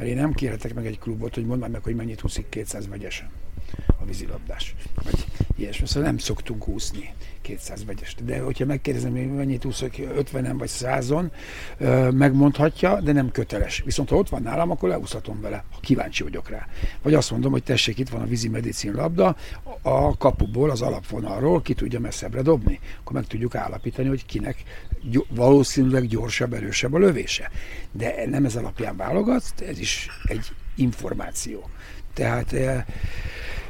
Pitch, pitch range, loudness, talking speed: 115 Hz, 100-135 Hz, -24 LUFS, 155 wpm